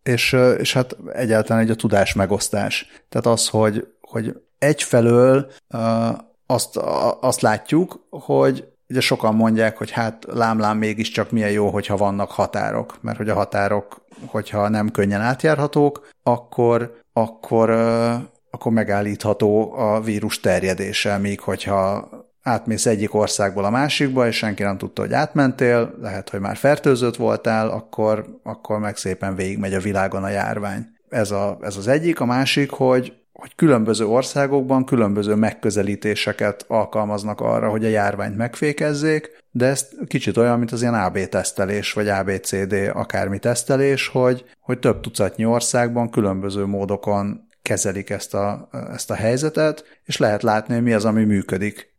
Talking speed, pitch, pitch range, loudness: 145 wpm, 110 Hz, 100-120 Hz, -20 LUFS